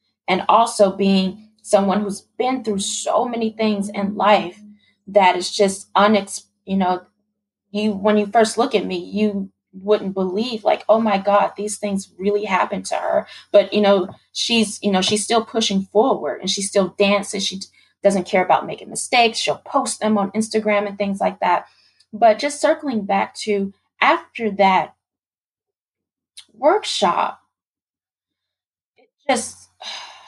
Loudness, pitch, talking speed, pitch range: -19 LUFS, 205 Hz, 155 wpm, 195-220 Hz